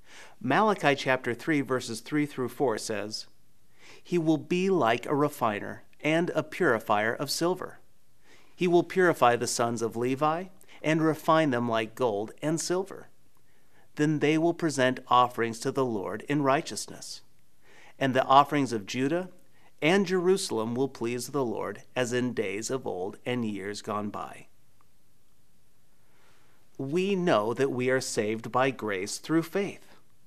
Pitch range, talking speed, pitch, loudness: 120-160 Hz, 145 wpm, 135 Hz, -28 LUFS